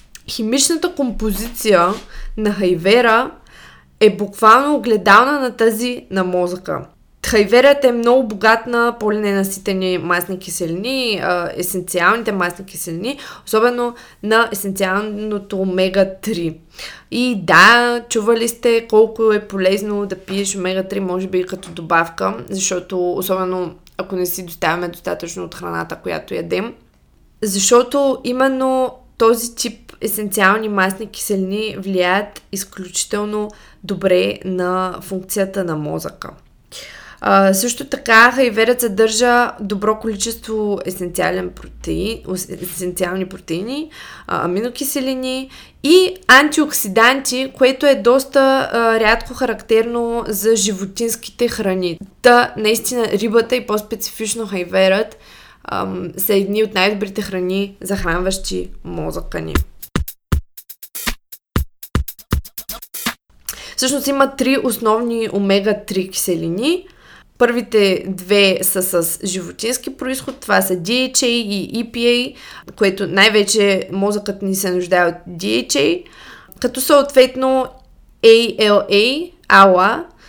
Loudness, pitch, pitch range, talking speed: -16 LUFS, 210 Hz, 185-240 Hz, 100 wpm